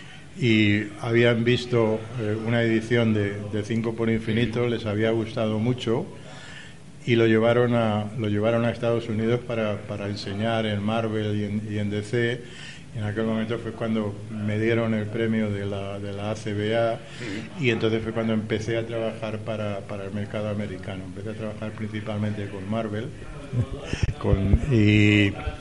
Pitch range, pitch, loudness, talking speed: 105-115 Hz, 110 Hz, -25 LUFS, 160 wpm